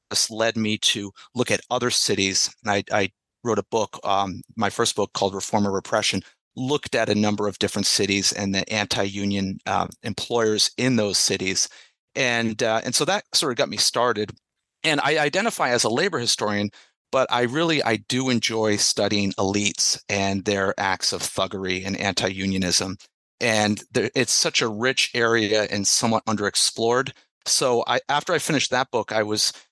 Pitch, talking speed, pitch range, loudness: 105 Hz, 180 wpm, 100-115 Hz, -22 LUFS